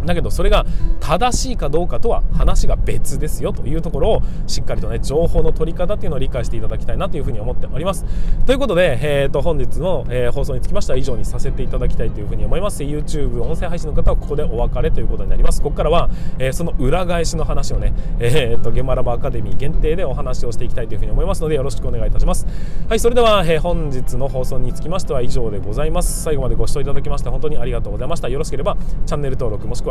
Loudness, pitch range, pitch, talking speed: -21 LUFS, 125-165 Hz, 140 Hz, 550 characters per minute